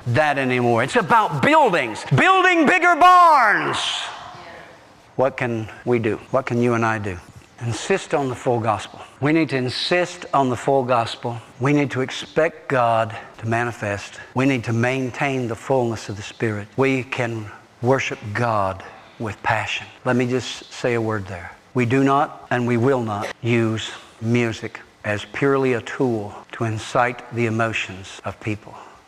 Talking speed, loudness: 165 wpm, -20 LUFS